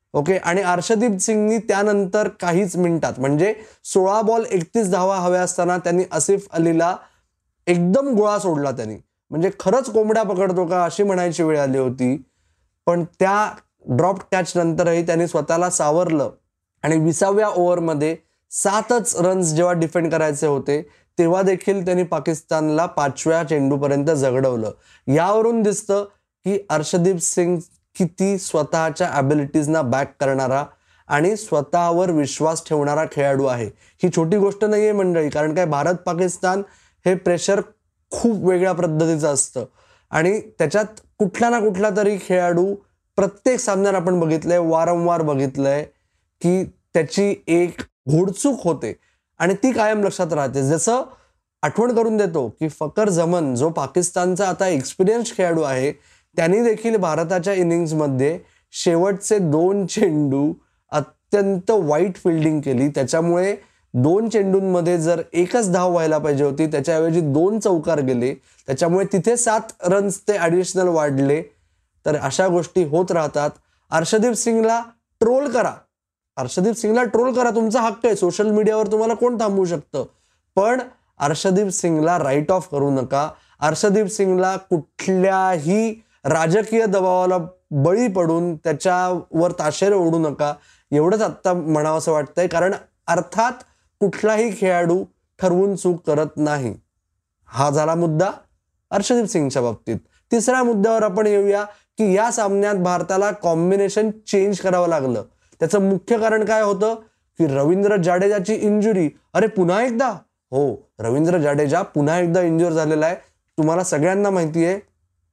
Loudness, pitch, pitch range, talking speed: -19 LUFS, 180 Hz, 155-200 Hz, 130 wpm